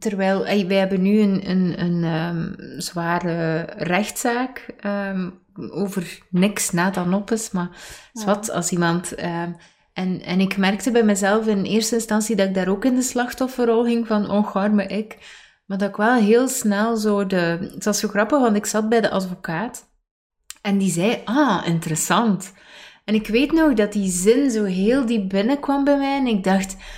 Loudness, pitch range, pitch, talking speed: -20 LUFS, 185-230 Hz, 205 Hz, 185 wpm